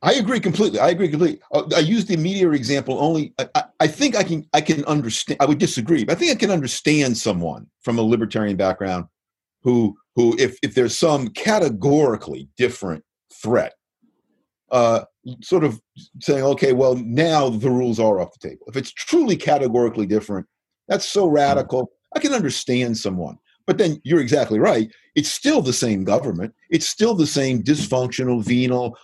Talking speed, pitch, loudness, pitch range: 175 wpm, 135 Hz, -20 LUFS, 120-165 Hz